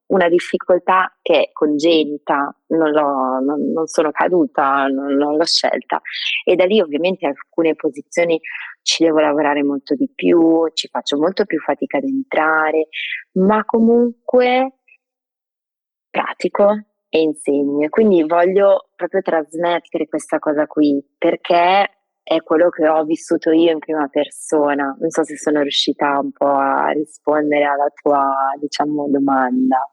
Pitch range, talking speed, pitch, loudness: 145-175 Hz, 140 wpm, 155 Hz, -17 LUFS